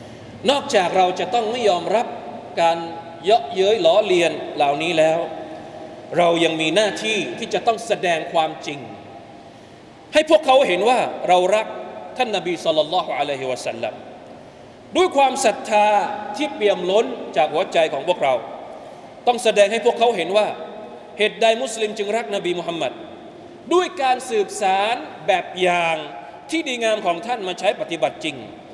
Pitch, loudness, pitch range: 215 Hz, -20 LUFS, 180-270 Hz